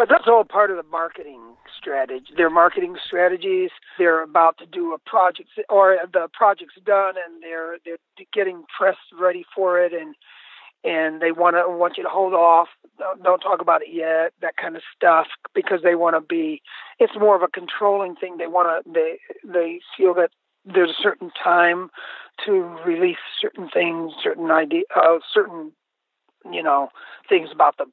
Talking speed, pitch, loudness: 175 wpm, 185 Hz, -20 LUFS